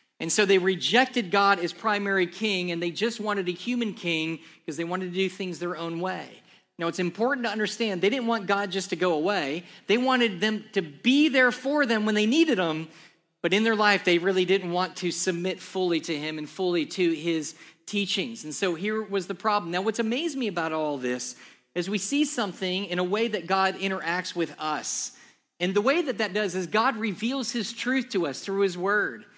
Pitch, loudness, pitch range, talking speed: 195 Hz, -26 LUFS, 175-220 Hz, 220 wpm